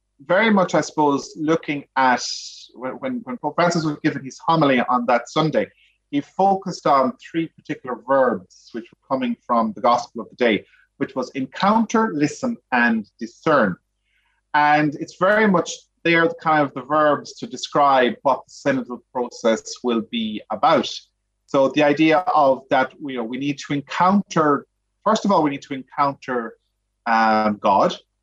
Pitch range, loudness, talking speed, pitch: 125-170 Hz, -20 LUFS, 165 wpm, 145 Hz